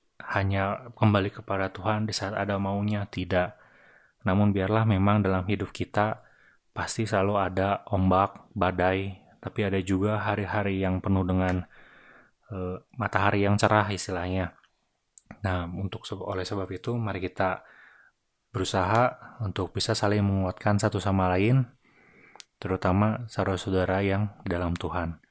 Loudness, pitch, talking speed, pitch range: -27 LUFS, 100 Hz, 125 wpm, 95-105 Hz